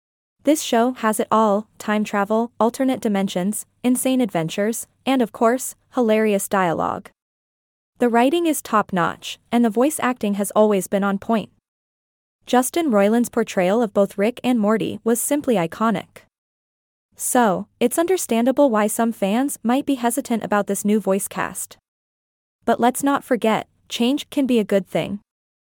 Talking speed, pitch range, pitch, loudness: 150 wpm, 205-250 Hz, 230 Hz, -20 LUFS